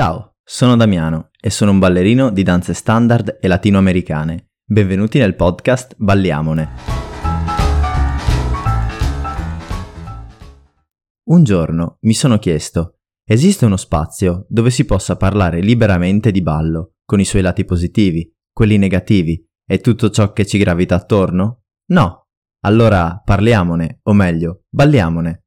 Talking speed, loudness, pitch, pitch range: 120 wpm, -14 LUFS, 95 Hz, 85-110 Hz